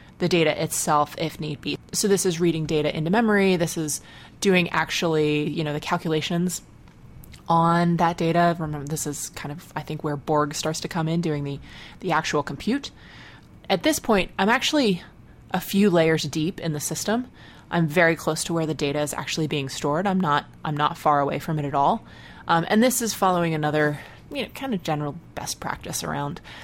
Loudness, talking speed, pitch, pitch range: -24 LUFS, 200 wpm, 160 Hz, 150-180 Hz